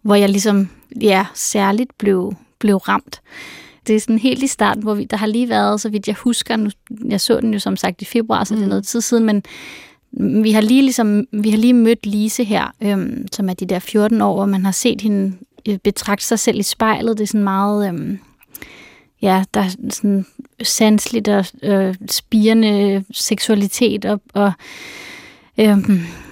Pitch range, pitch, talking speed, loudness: 200-230 Hz, 215 Hz, 190 wpm, -16 LUFS